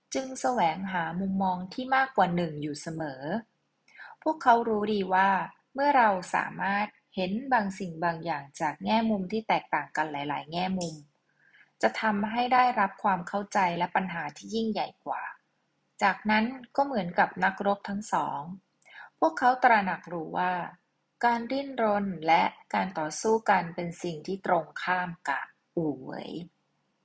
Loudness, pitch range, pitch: -28 LUFS, 175-220 Hz, 195 Hz